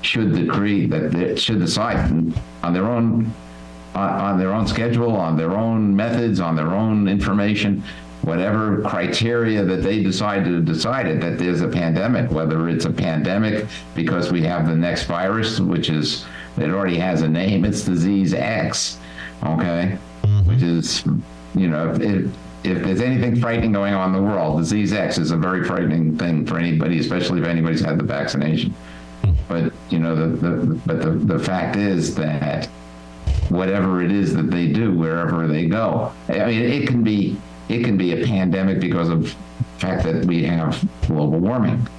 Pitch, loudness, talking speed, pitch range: 85 Hz, -20 LUFS, 175 wpm, 80-100 Hz